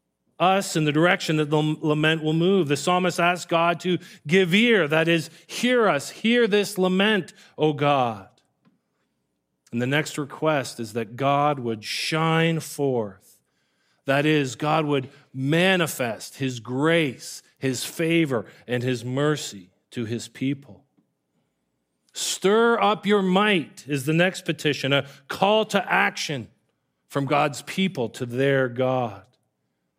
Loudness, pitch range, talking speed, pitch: -23 LUFS, 130-175 Hz, 135 wpm, 150 Hz